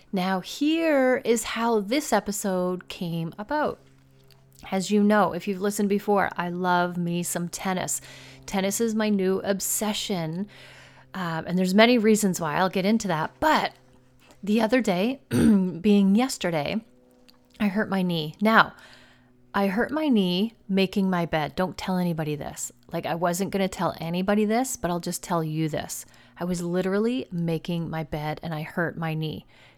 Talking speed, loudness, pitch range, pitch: 165 wpm, -25 LUFS, 165-210 Hz, 185 Hz